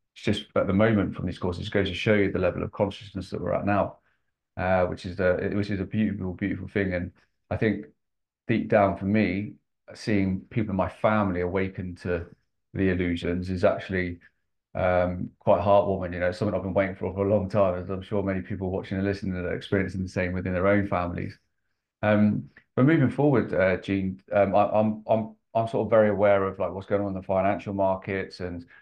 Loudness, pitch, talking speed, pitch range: -26 LUFS, 95 Hz, 210 wpm, 90-105 Hz